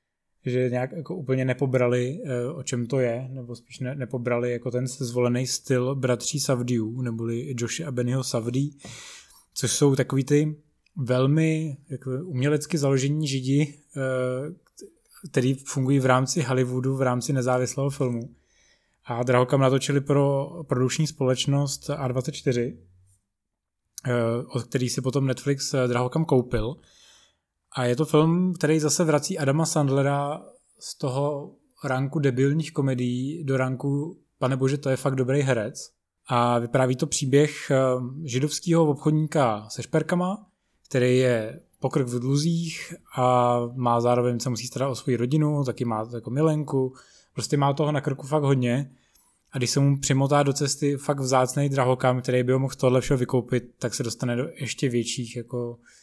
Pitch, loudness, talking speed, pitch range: 130 Hz, -25 LUFS, 145 wpm, 125-145 Hz